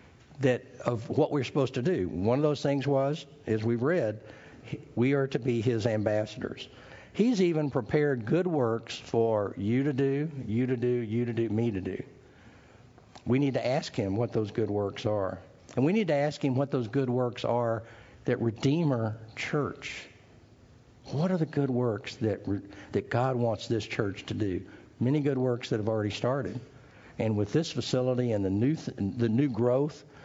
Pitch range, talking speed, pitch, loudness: 110-140 Hz, 185 wpm, 125 Hz, -29 LUFS